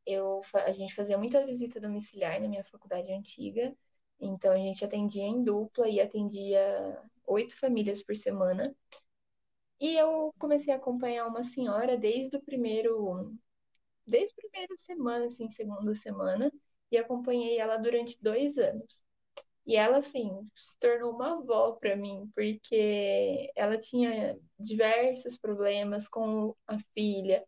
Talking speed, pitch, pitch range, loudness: 140 wpm, 225 Hz, 205-255 Hz, -31 LUFS